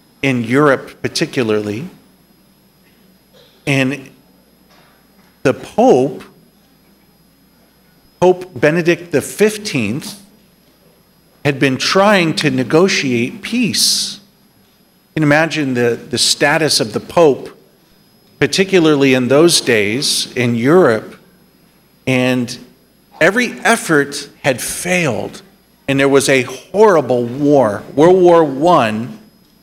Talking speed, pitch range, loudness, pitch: 90 wpm, 130-190 Hz, -14 LUFS, 150 Hz